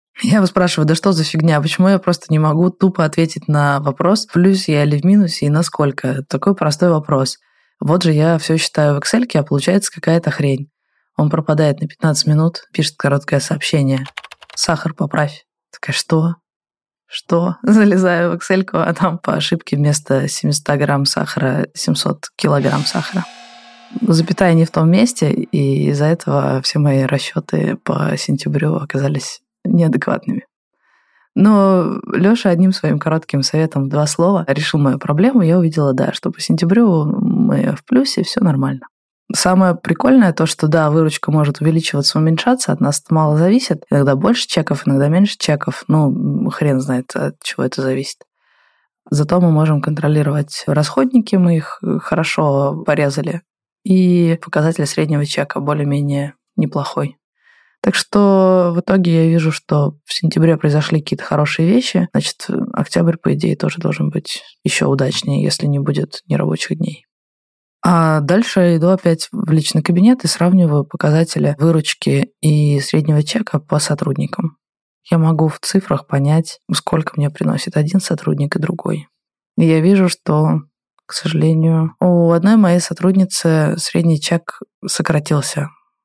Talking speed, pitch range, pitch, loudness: 145 wpm, 150-185 Hz, 165 Hz, -15 LUFS